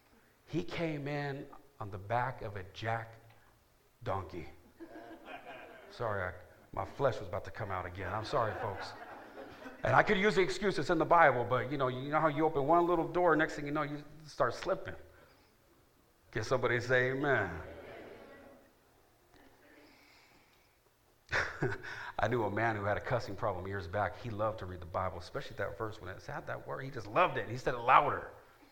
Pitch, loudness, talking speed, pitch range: 120 Hz, -34 LUFS, 185 wpm, 105-150 Hz